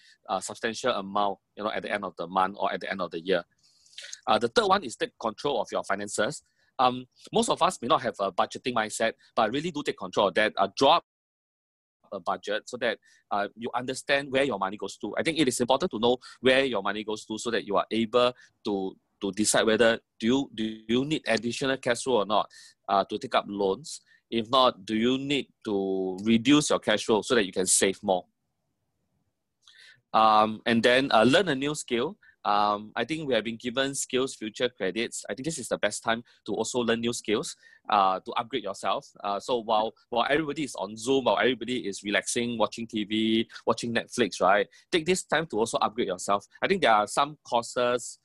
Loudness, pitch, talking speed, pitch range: -27 LUFS, 115 Hz, 220 wpm, 105-125 Hz